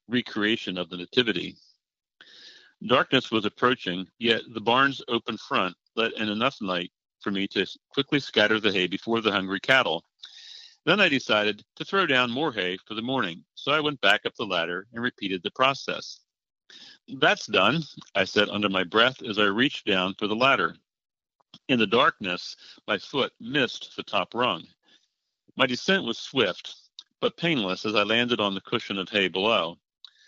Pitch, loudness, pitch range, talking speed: 110 Hz, -25 LUFS, 100-130 Hz, 170 wpm